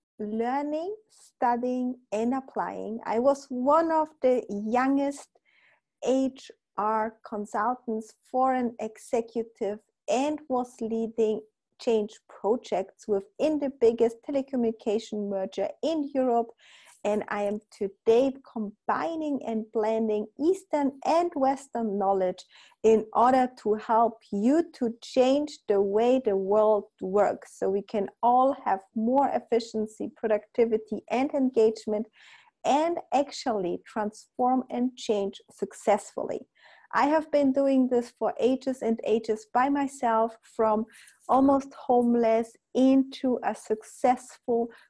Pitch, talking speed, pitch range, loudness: 235 Hz, 110 wpm, 215-265 Hz, -27 LUFS